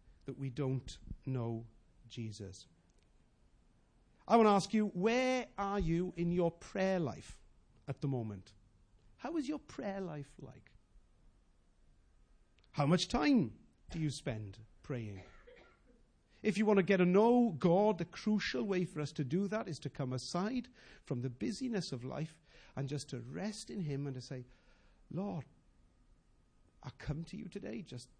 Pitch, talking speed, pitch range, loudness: 150 Hz, 155 wpm, 120-200 Hz, -36 LUFS